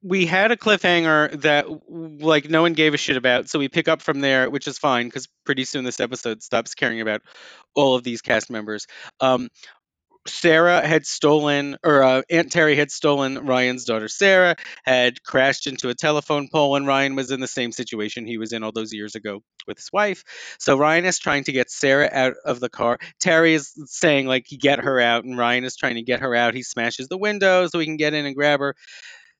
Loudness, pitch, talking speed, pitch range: -20 LUFS, 140 Hz, 220 wpm, 125-155 Hz